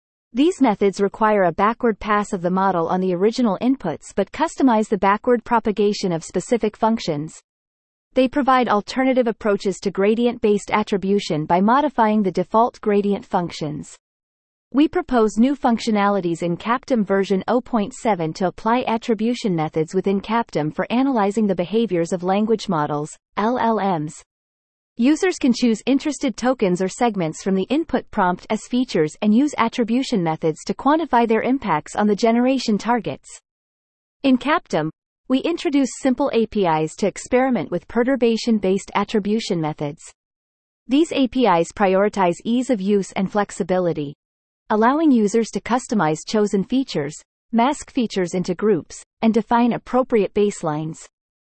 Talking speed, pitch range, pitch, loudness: 135 wpm, 185-245 Hz, 215 Hz, -20 LUFS